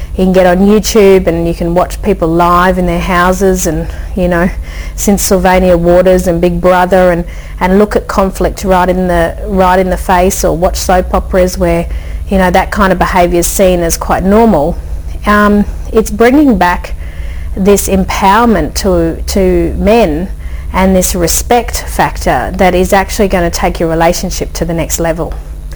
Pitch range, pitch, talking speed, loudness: 170-195 Hz, 180 Hz, 175 wpm, -9 LUFS